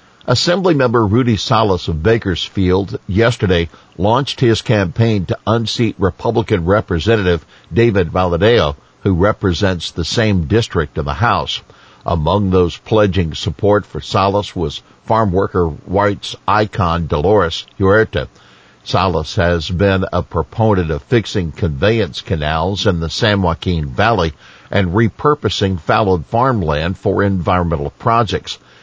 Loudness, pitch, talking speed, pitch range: -15 LUFS, 100 Hz, 120 wpm, 85-110 Hz